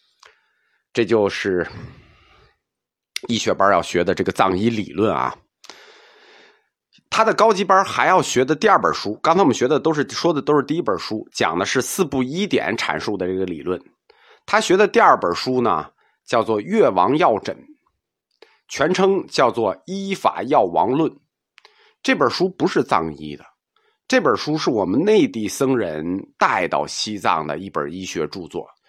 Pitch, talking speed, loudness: 190 Hz, 230 characters per minute, -19 LUFS